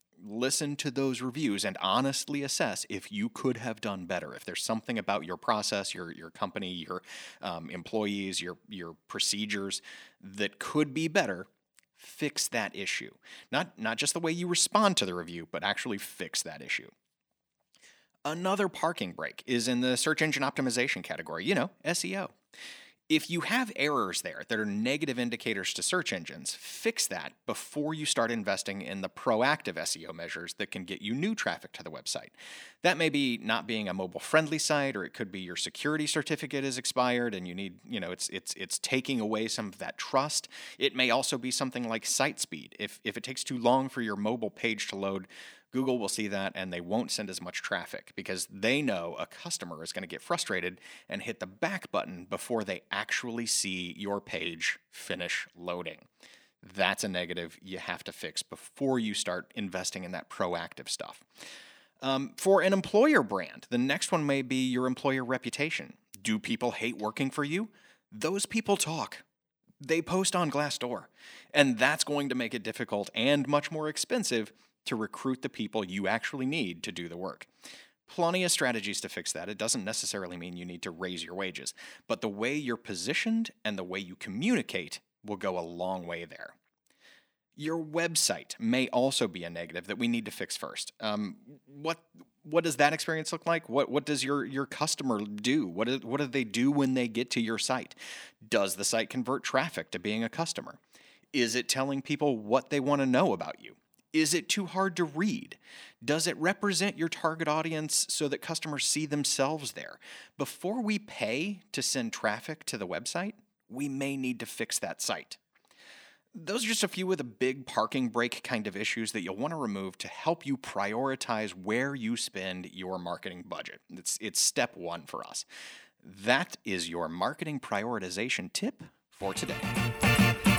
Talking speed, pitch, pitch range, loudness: 190 wpm, 135 Hz, 110-160 Hz, -31 LUFS